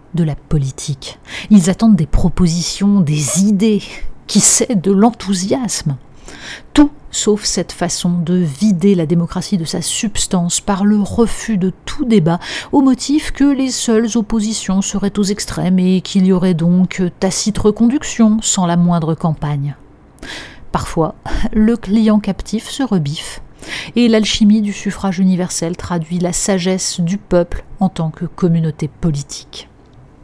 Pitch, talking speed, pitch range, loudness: 190 Hz, 140 wpm, 170-215 Hz, -15 LUFS